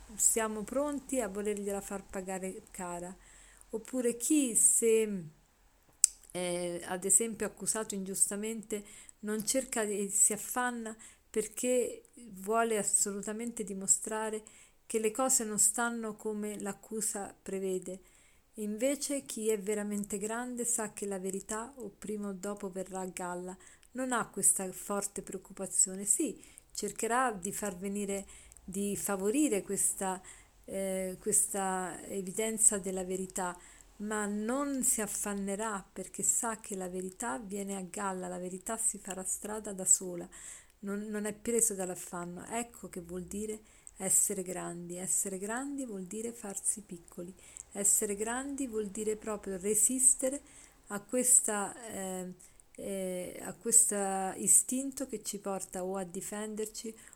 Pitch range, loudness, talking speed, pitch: 190-220 Hz, -32 LUFS, 125 wpm, 205 Hz